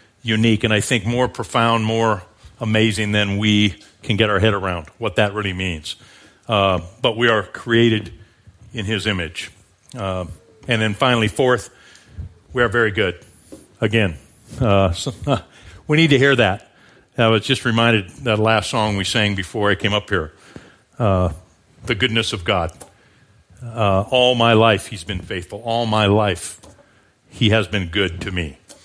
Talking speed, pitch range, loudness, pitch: 165 wpm, 95-115 Hz, -18 LUFS, 110 Hz